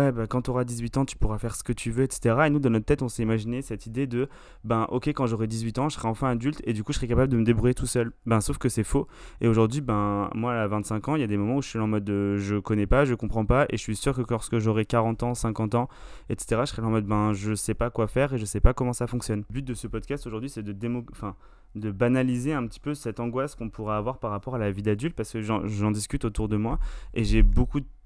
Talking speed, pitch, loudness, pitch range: 300 wpm, 115 Hz, -27 LUFS, 110-125 Hz